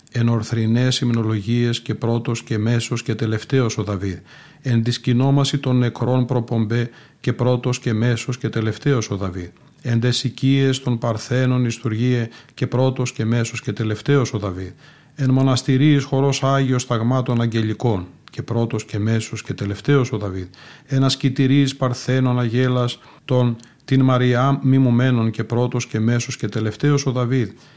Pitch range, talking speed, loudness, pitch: 115-130 Hz, 145 wpm, -20 LUFS, 120 Hz